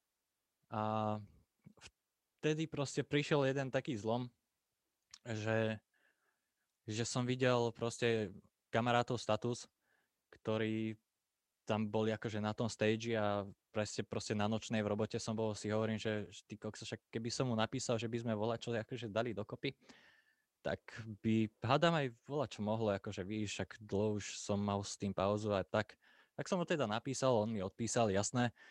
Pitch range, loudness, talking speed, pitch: 105-120 Hz, -38 LUFS, 155 wpm, 110 Hz